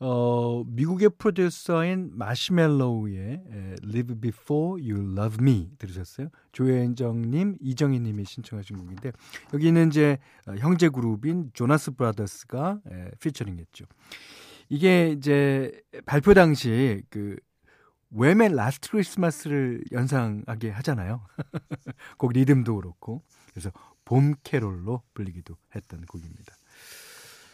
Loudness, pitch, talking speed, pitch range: -25 LUFS, 130 Hz, 290 characters per minute, 110-150 Hz